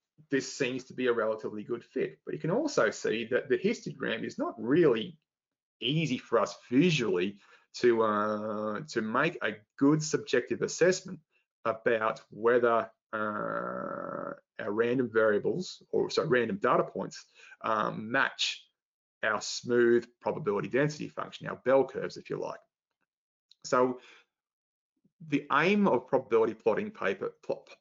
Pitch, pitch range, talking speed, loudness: 135 Hz, 120-185 Hz, 135 wpm, -30 LUFS